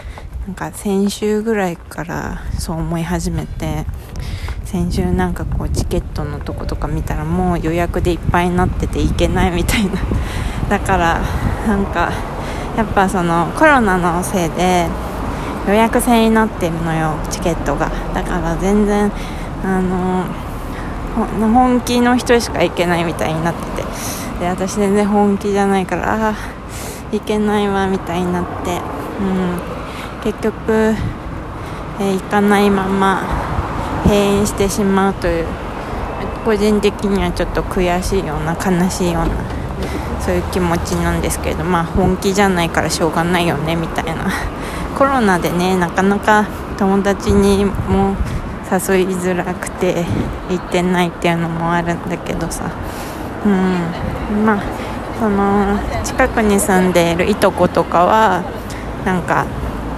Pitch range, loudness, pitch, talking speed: 170-205 Hz, -17 LUFS, 185 Hz, 280 characters per minute